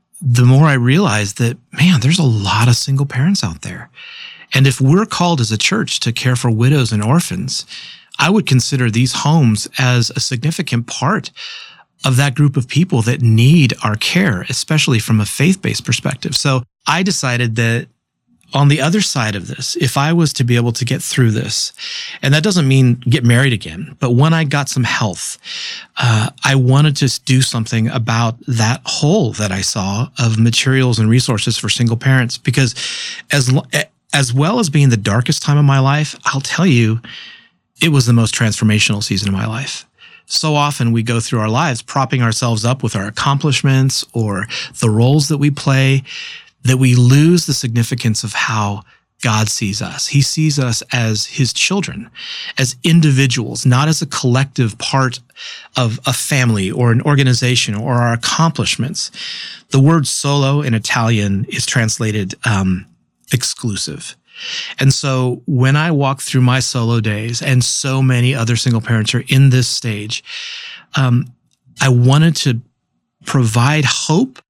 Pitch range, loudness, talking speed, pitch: 115-145 Hz, -14 LUFS, 170 wpm, 130 Hz